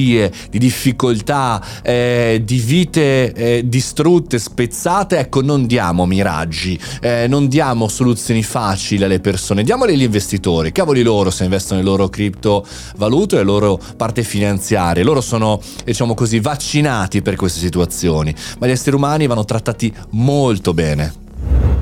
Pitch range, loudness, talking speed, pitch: 95-125 Hz, -15 LUFS, 140 wpm, 110 Hz